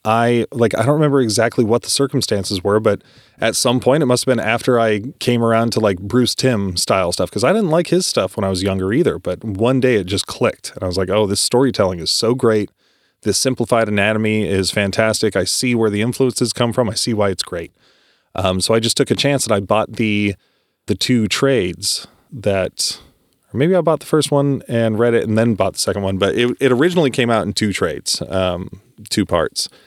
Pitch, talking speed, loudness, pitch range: 115 Hz, 230 wpm, -17 LUFS, 100-125 Hz